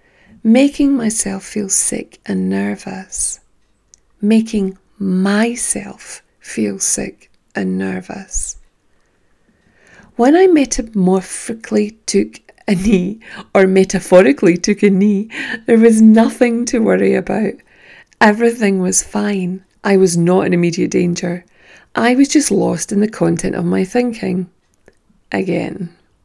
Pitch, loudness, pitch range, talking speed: 195 Hz, -15 LUFS, 175-220 Hz, 110 wpm